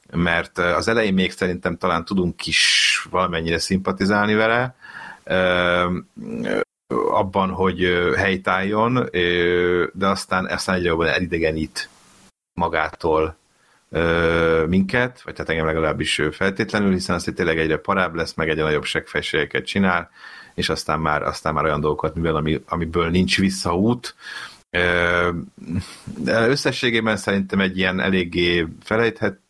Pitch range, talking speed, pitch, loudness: 85-95 Hz, 120 wpm, 90 Hz, -20 LUFS